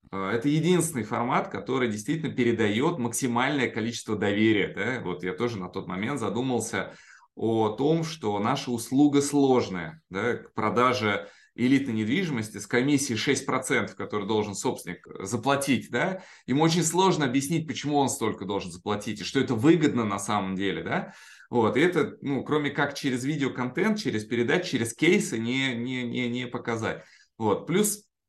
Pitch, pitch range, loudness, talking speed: 125 Hz, 110-140 Hz, -26 LUFS, 150 wpm